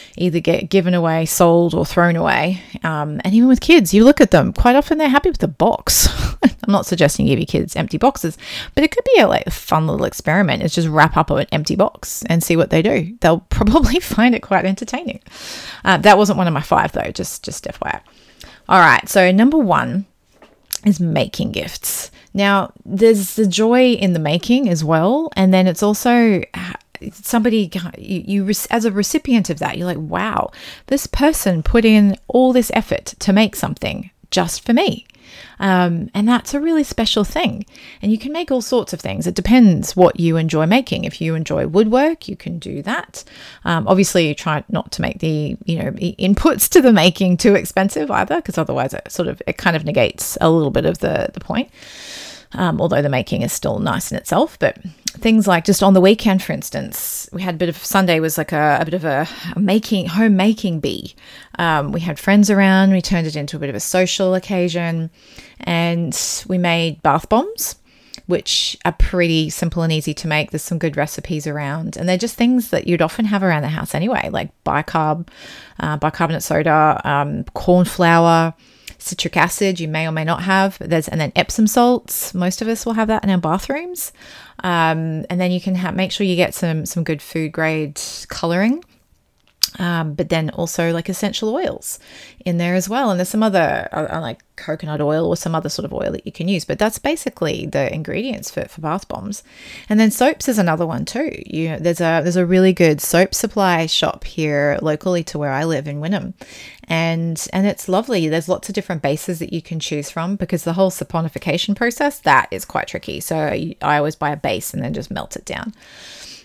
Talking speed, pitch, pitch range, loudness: 210 wpm, 185 Hz, 165-215 Hz, -17 LUFS